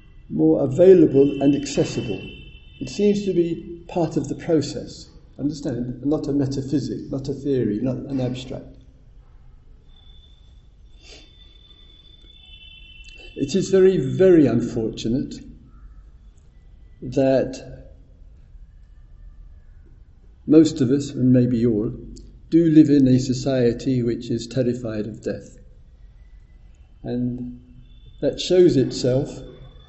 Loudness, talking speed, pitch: -20 LUFS, 95 wpm, 125 Hz